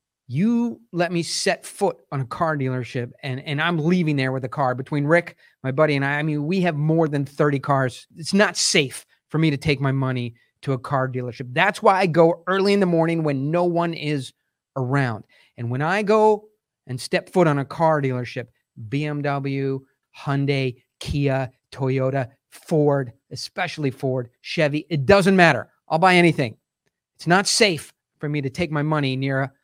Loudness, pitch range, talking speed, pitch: -21 LUFS, 130-170 Hz, 190 wpm, 145 Hz